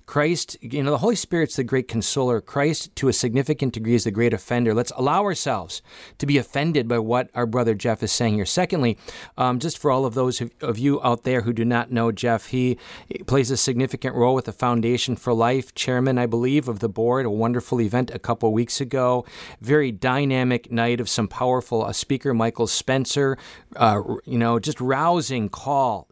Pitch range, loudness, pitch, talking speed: 115-135 Hz, -22 LUFS, 125 Hz, 205 wpm